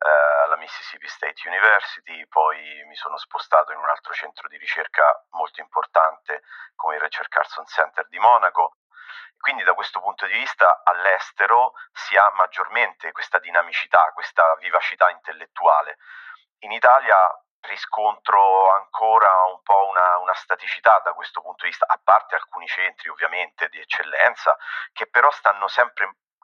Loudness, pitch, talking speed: -19 LUFS, 110 Hz, 145 wpm